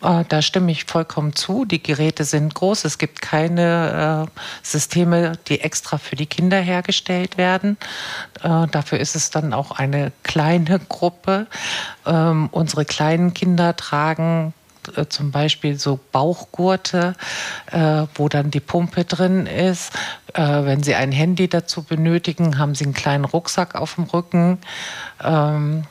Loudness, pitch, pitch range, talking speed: -19 LUFS, 160 Hz, 150-175 Hz, 145 wpm